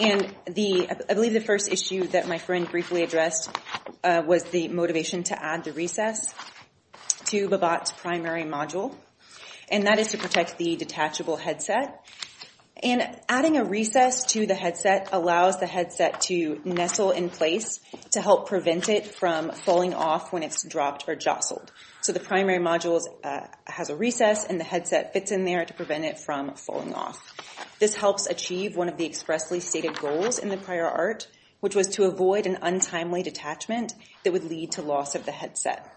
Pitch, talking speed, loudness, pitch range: 180 Hz, 175 wpm, -26 LUFS, 170-200 Hz